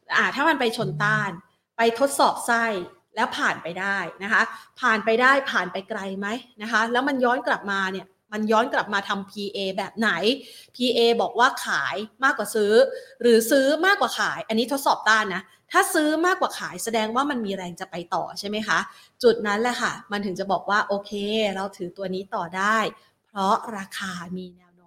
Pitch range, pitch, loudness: 195-245 Hz, 220 Hz, -23 LUFS